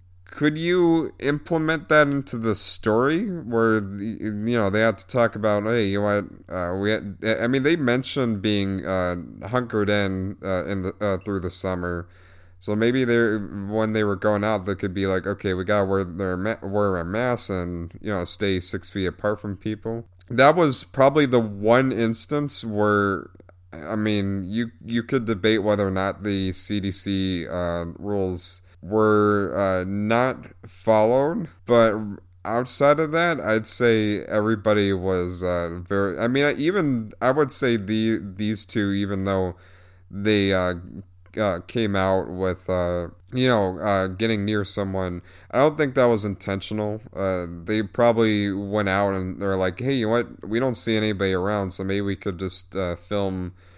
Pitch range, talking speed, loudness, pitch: 95-115 Hz, 175 wpm, -23 LUFS, 105 Hz